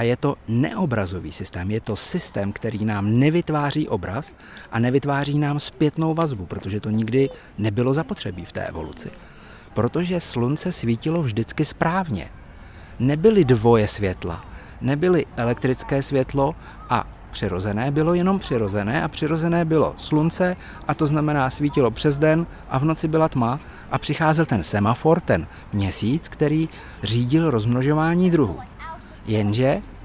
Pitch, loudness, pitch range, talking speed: 130 Hz, -22 LUFS, 110-155 Hz, 135 wpm